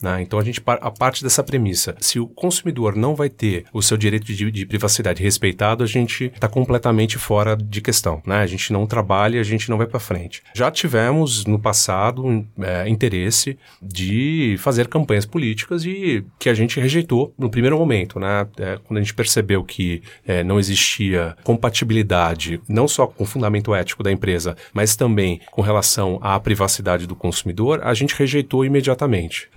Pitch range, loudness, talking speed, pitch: 100-125 Hz, -19 LUFS, 180 wpm, 110 Hz